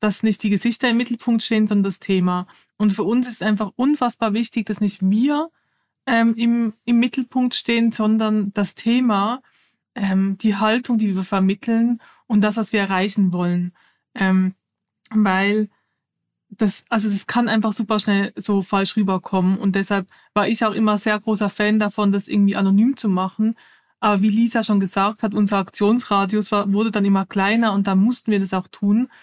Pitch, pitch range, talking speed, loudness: 210 Hz, 200-230 Hz, 180 wpm, -19 LUFS